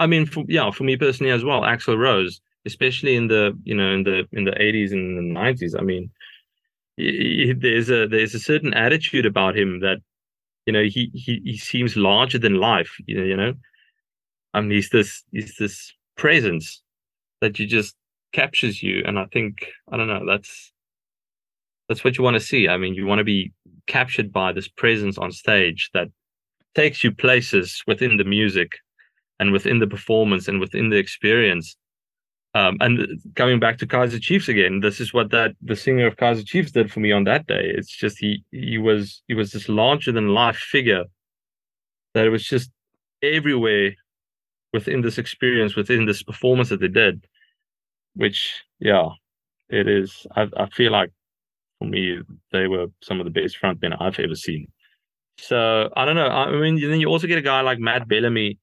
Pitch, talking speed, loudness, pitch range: 110 Hz, 190 wpm, -20 LUFS, 100-130 Hz